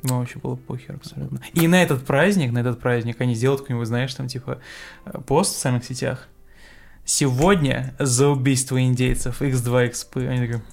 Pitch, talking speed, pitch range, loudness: 130 Hz, 160 wpm, 125-140 Hz, -21 LUFS